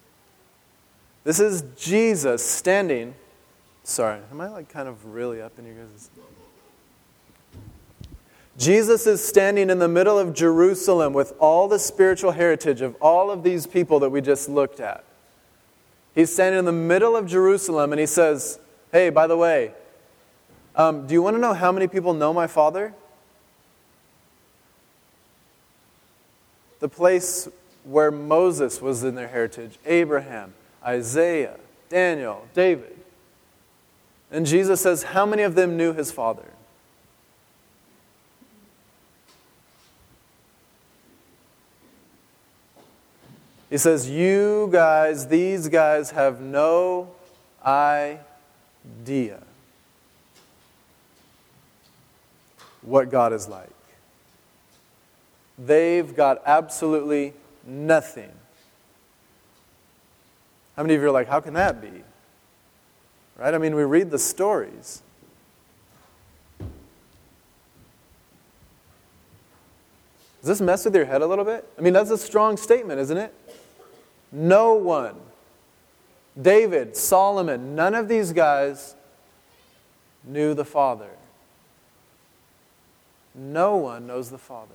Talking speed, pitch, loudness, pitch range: 110 wpm, 155 Hz, -21 LUFS, 130-185 Hz